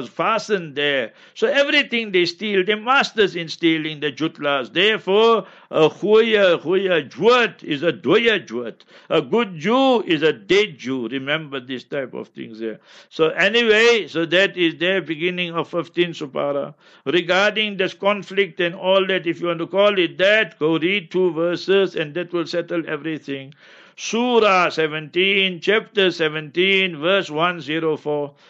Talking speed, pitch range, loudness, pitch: 160 wpm, 160-200 Hz, -19 LUFS, 175 Hz